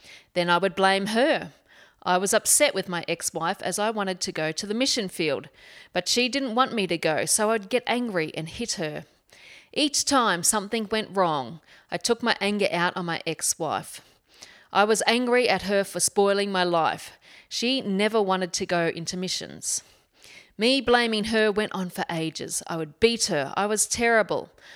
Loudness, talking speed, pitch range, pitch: -24 LUFS, 190 wpm, 175-225 Hz, 200 Hz